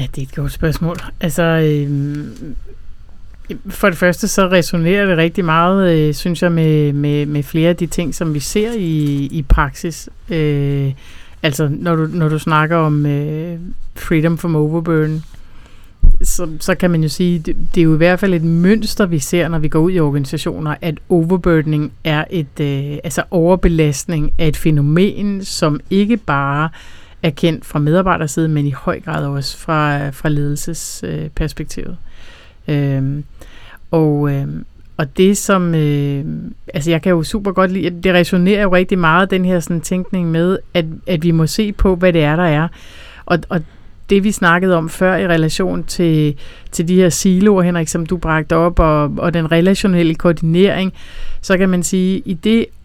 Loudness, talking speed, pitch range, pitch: -15 LUFS, 180 wpm, 150-180 Hz, 165 Hz